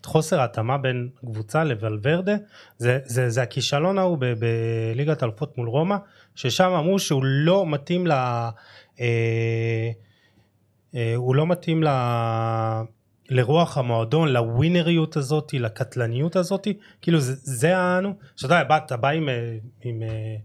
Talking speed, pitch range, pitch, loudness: 125 wpm, 115-160 Hz, 130 Hz, -23 LUFS